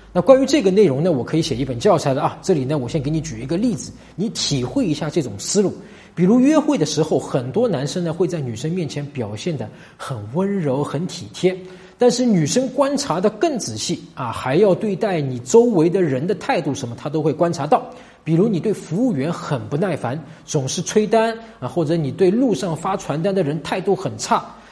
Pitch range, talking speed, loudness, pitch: 145-200 Hz, 310 characters per minute, -19 LUFS, 170 Hz